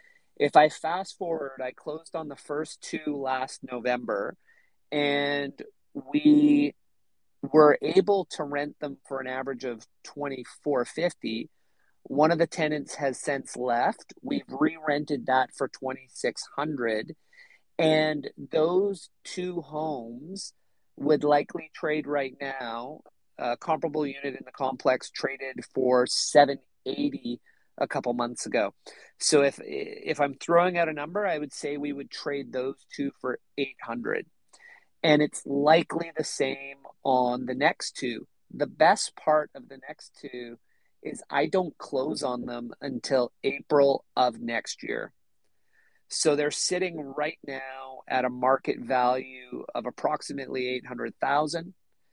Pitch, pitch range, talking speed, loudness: 145 Hz, 130-160 Hz, 130 wpm, -27 LUFS